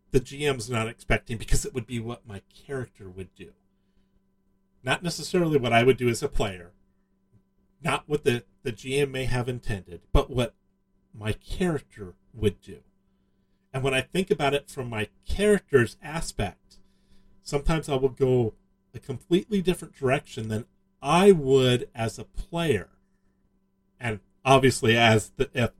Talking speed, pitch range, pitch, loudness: 150 wpm, 95-135 Hz, 115 Hz, -26 LUFS